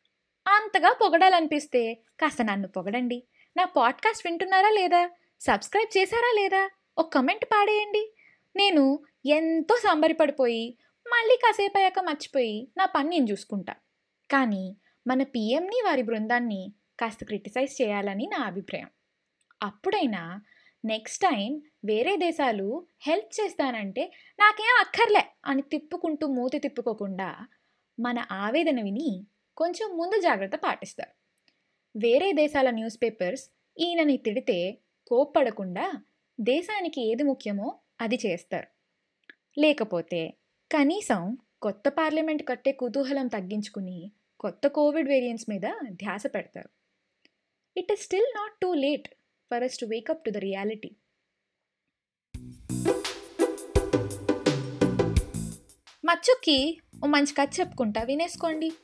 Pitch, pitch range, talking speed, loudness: 280 Hz, 225-345 Hz, 100 wpm, -26 LUFS